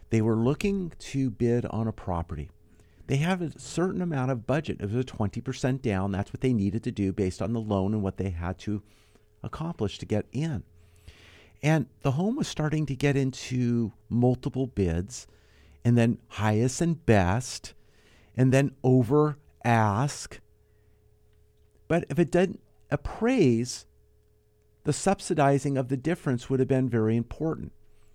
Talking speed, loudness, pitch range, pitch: 155 wpm, -27 LUFS, 105-140 Hz, 115 Hz